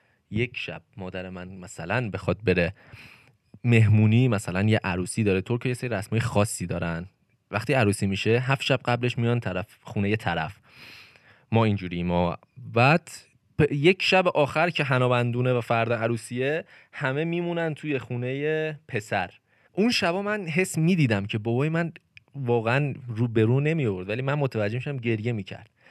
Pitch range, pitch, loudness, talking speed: 105-140 Hz, 120 Hz, -25 LUFS, 155 wpm